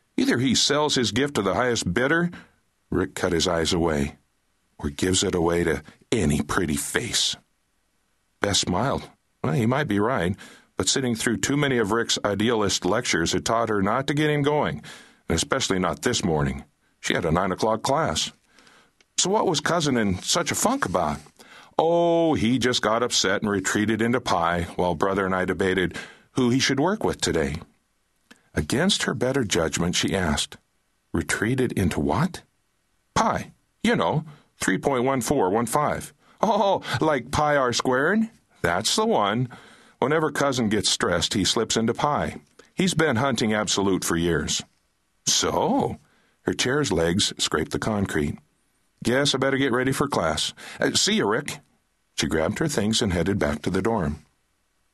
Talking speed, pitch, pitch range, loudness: 160 wpm, 115 Hz, 95-140 Hz, -23 LUFS